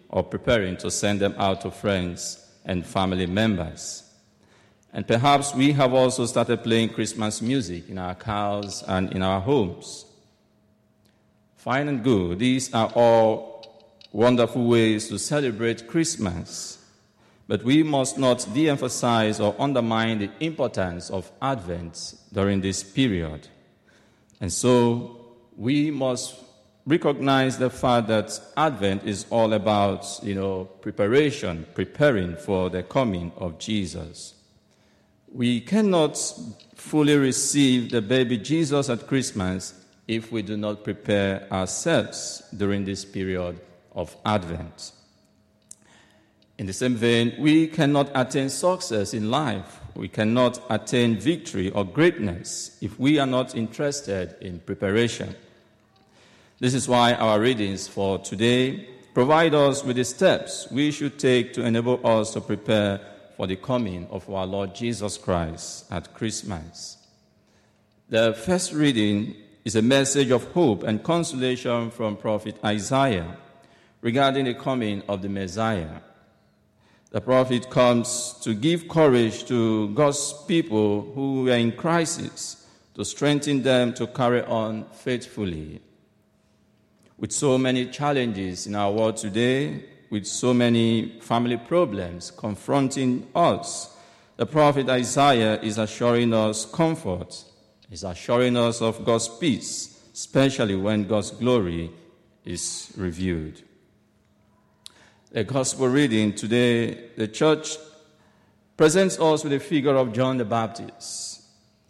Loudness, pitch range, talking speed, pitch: -23 LUFS, 100-130 Hz, 125 wpm, 115 Hz